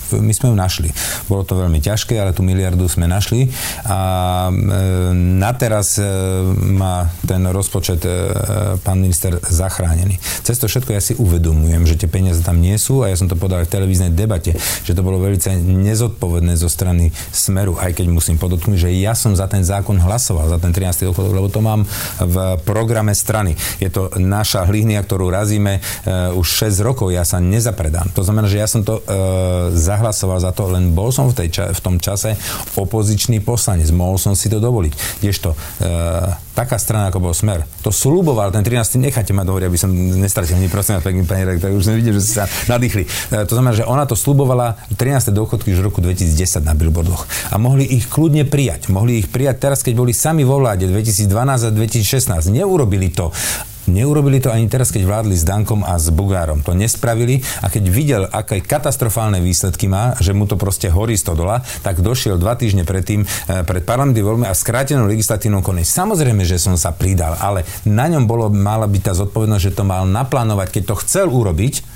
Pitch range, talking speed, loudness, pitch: 90-110 Hz, 200 wpm, -16 LUFS, 100 Hz